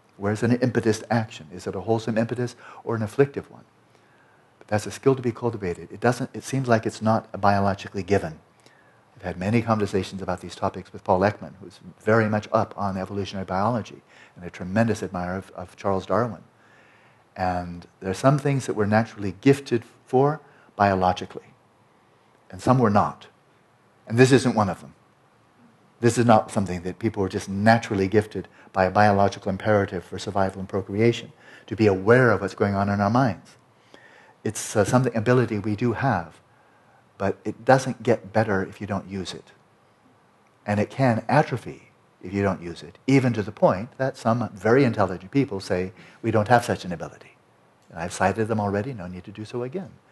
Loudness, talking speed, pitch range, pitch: -24 LUFS, 190 wpm, 95-120 Hz, 105 Hz